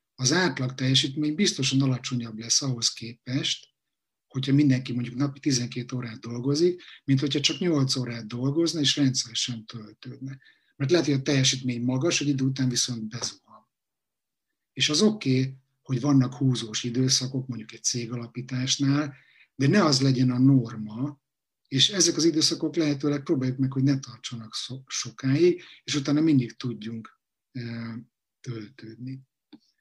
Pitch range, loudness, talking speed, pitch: 120-145 Hz, -25 LUFS, 140 wpm, 130 Hz